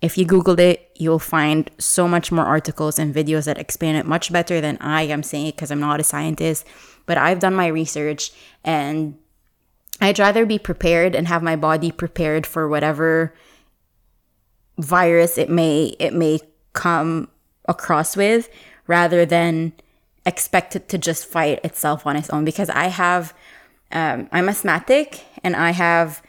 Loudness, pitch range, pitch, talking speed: -19 LUFS, 155-175 Hz, 165 Hz, 165 wpm